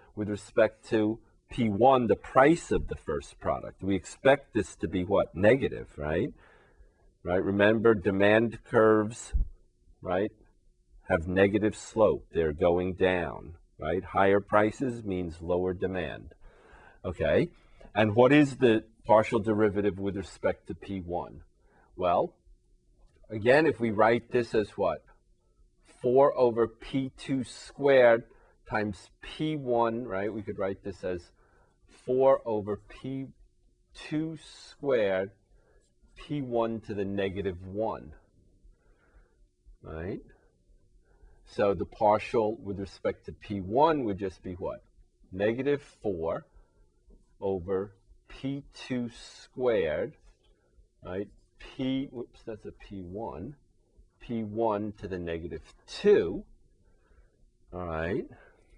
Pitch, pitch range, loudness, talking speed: 105 Hz, 95-115 Hz, -28 LUFS, 105 wpm